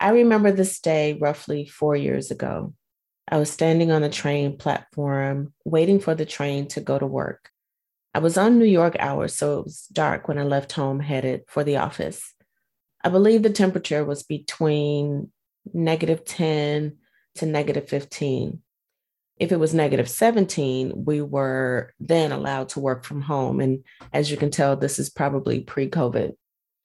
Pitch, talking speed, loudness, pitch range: 150 Hz, 170 wpm, -23 LUFS, 140-160 Hz